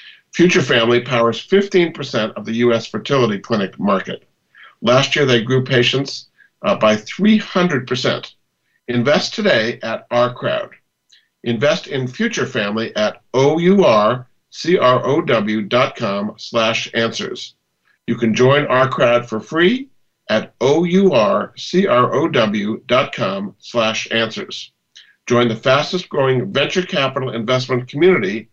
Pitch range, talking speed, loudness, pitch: 115-170 Hz, 105 wpm, -16 LUFS, 130 Hz